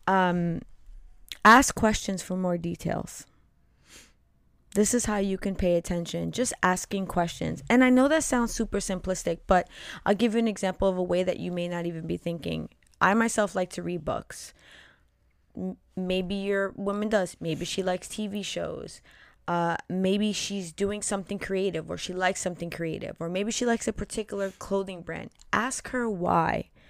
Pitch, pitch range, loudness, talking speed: 185 Hz, 175-205 Hz, -27 LUFS, 170 wpm